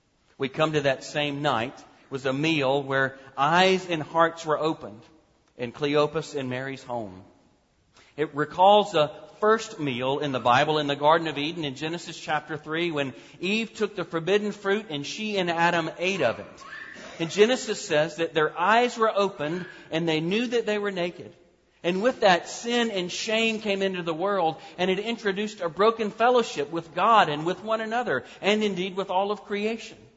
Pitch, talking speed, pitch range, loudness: 170 Hz, 185 wpm, 150-205 Hz, -25 LUFS